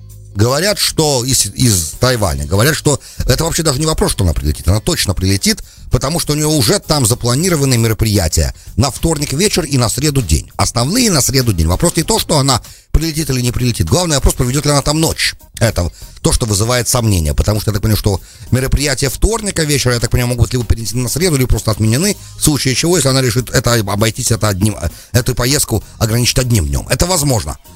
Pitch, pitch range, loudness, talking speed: 125 Hz, 105-145 Hz, -14 LUFS, 205 wpm